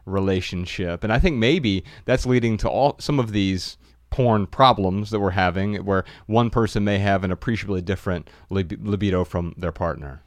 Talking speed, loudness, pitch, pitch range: 175 wpm, -22 LUFS, 95 Hz, 90-110 Hz